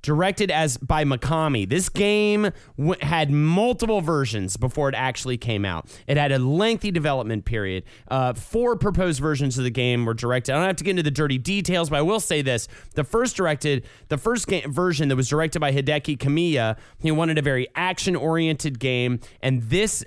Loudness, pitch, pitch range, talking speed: -23 LUFS, 150 Hz, 130-180 Hz, 195 wpm